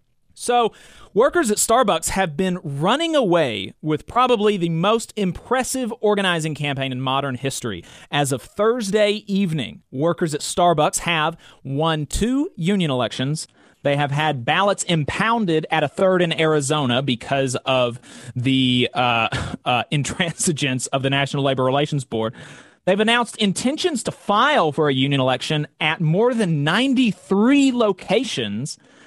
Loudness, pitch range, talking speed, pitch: -20 LUFS, 140-205 Hz, 135 wpm, 160 Hz